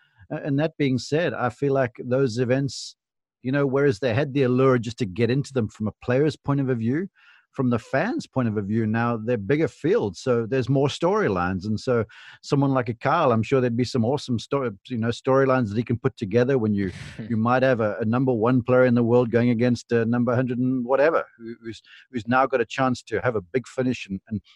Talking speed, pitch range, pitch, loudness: 230 wpm, 115-135 Hz, 125 Hz, -23 LUFS